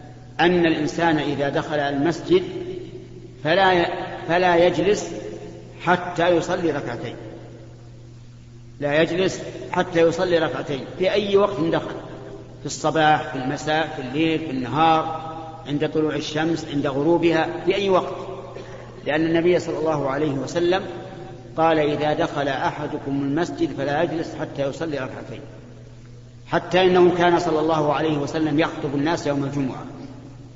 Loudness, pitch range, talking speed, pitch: -21 LUFS, 135-170 Hz, 120 wpm, 155 Hz